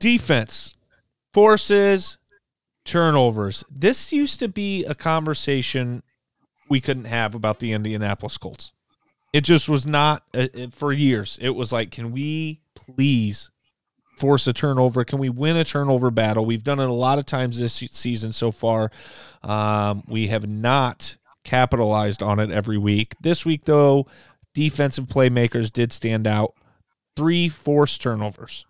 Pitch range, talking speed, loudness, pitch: 110-150 Hz, 140 wpm, -21 LUFS, 130 Hz